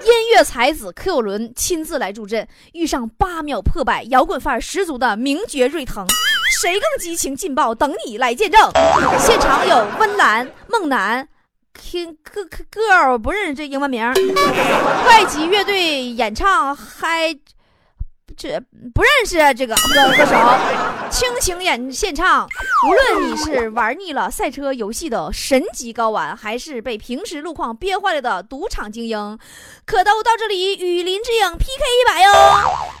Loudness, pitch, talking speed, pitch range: -16 LUFS, 315 Hz, 225 characters per minute, 250-385 Hz